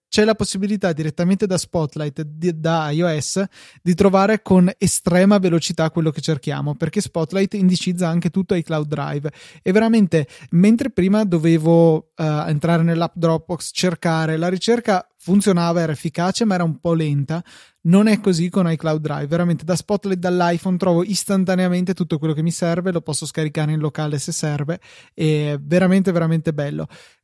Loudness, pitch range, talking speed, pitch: -19 LUFS, 160-190 Hz, 165 wpm, 170 Hz